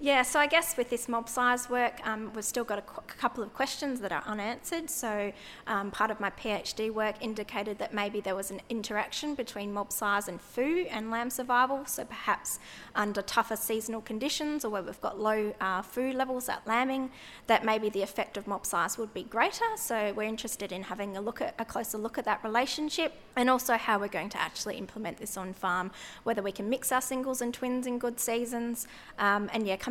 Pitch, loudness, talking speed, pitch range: 225 Hz, -31 LUFS, 220 wpm, 205-250 Hz